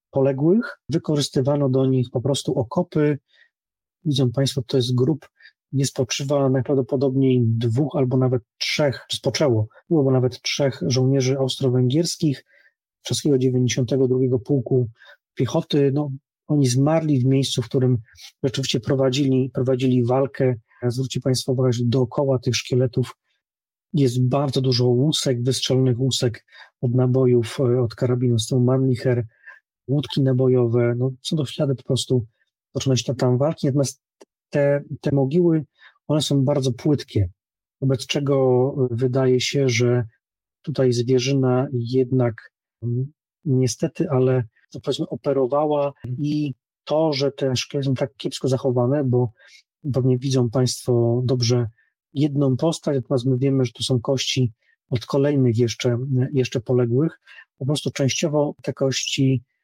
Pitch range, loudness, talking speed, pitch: 125-140 Hz, -21 LUFS, 130 wpm, 130 Hz